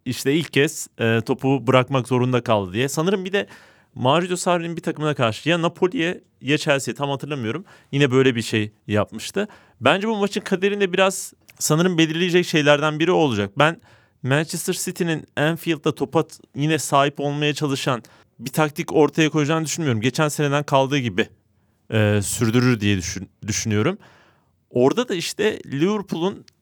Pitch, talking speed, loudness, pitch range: 145 Hz, 145 wpm, -21 LUFS, 120-165 Hz